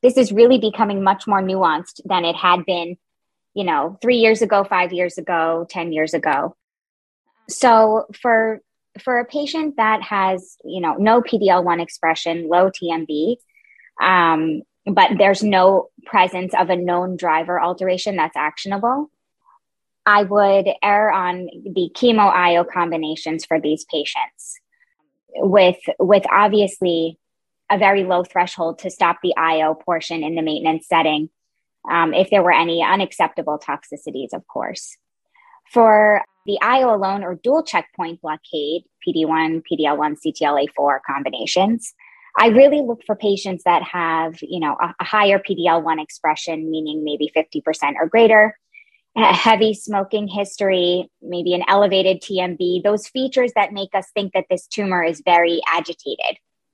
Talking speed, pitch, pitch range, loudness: 145 wpm, 185 Hz, 165-215 Hz, -18 LUFS